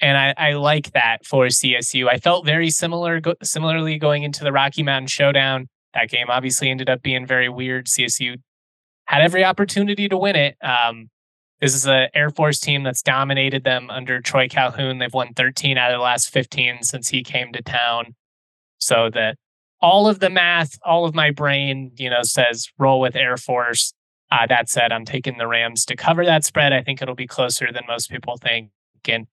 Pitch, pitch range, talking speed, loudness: 130 Hz, 125-145 Hz, 200 wpm, -18 LUFS